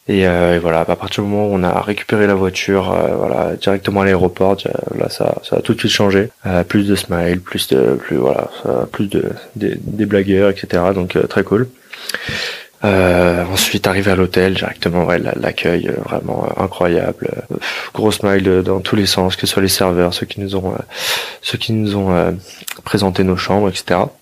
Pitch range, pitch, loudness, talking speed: 90-100 Hz, 95 Hz, -16 LUFS, 210 wpm